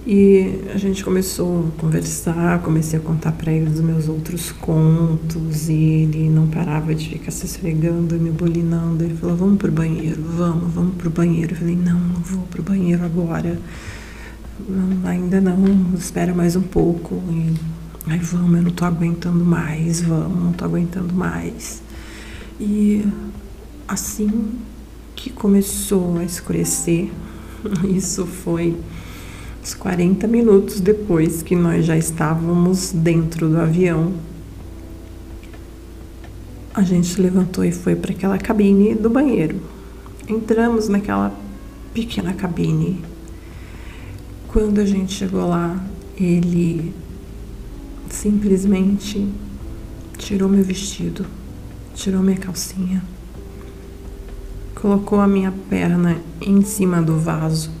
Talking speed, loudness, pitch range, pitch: 120 wpm, -19 LUFS, 160-190 Hz, 170 Hz